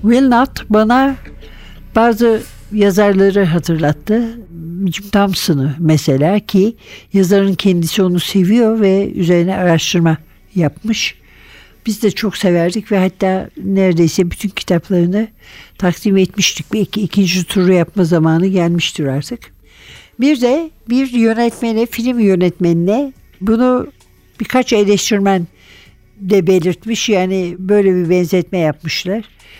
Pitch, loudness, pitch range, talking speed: 190 Hz, -14 LUFS, 175-215 Hz, 105 wpm